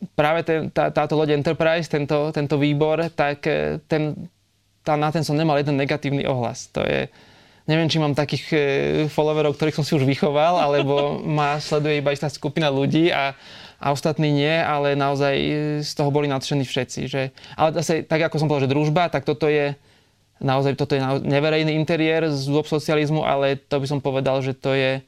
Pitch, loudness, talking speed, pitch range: 150 Hz, -21 LUFS, 190 wpm, 140-155 Hz